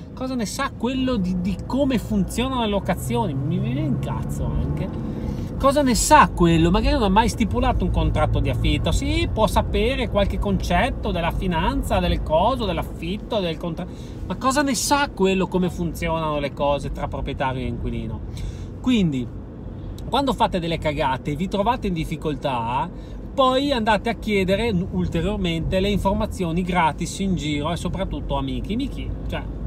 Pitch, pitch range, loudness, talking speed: 180 Hz, 140-220 Hz, -22 LUFS, 155 wpm